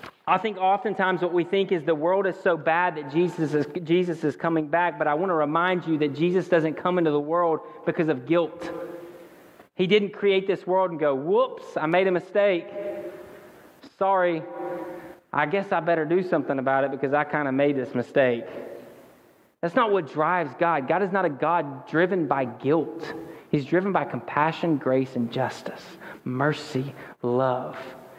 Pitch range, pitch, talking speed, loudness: 150-185 Hz, 170 Hz, 180 wpm, -24 LUFS